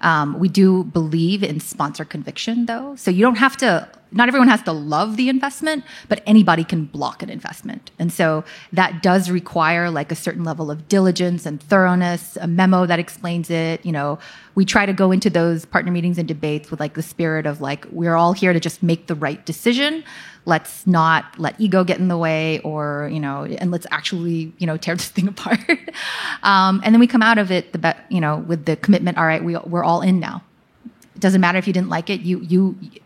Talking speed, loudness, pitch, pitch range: 225 wpm, -18 LUFS, 175 Hz, 160-195 Hz